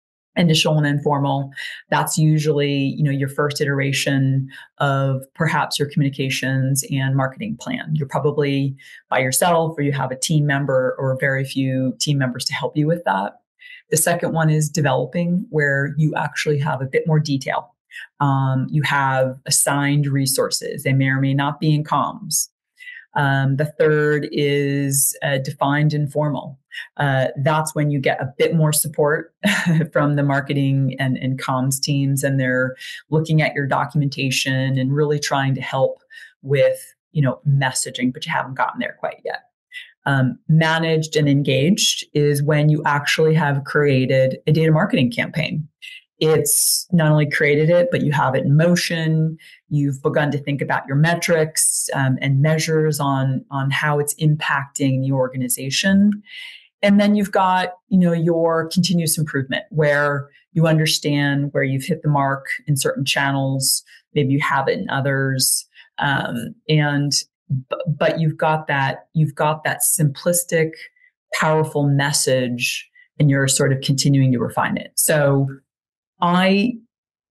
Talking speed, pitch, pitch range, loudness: 155 wpm, 145 Hz, 135-160 Hz, -19 LUFS